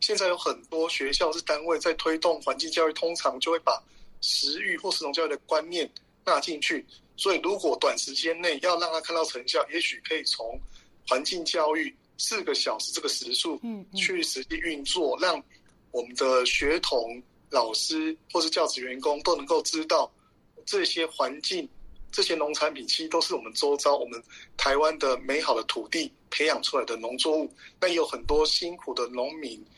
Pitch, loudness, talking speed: 175 Hz, -27 LUFS, 275 characters per minute